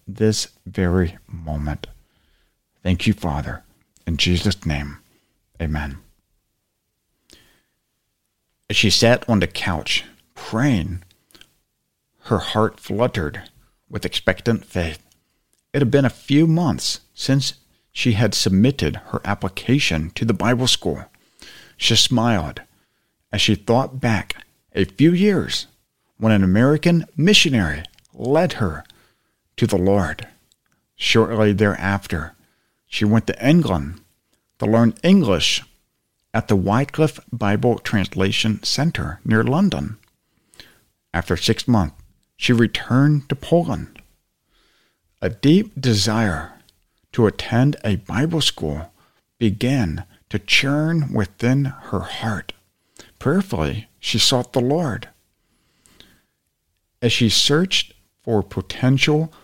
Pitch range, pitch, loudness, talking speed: 90-130 Hz, 110 Hz, -19 LUFS, 105 wpm